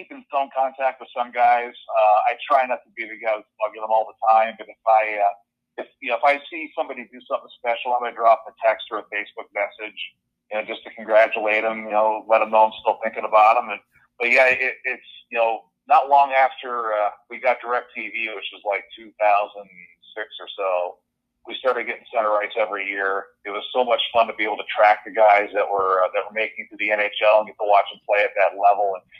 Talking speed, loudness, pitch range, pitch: 245 wpm, -21 LUFS, 105-120 Hz, 110 Hz